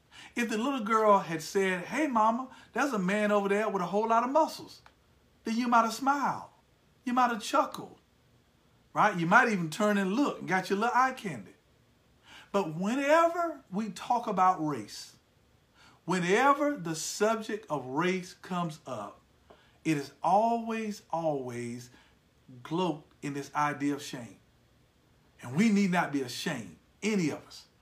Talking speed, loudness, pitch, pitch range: 155 wpm, -29 LUFS, 200 Hz, 160-230 Hz